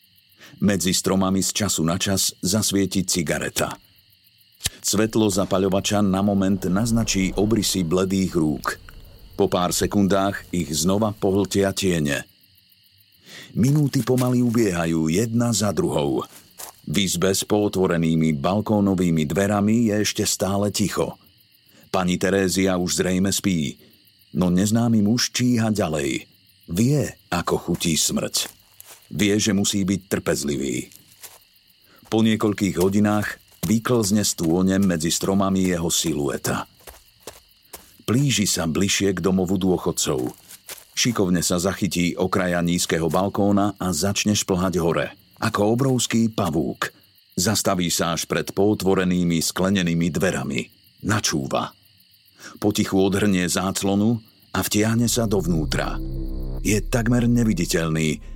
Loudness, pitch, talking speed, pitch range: -21 LUFS, 100 Hz, 105 wpm, 90-105 Hz